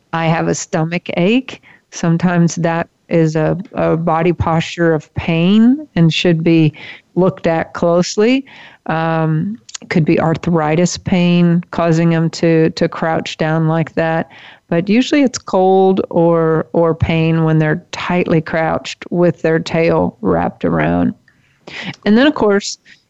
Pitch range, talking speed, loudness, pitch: 160-180 Hz, 140 wpm, -15 LUFS, 170 Hz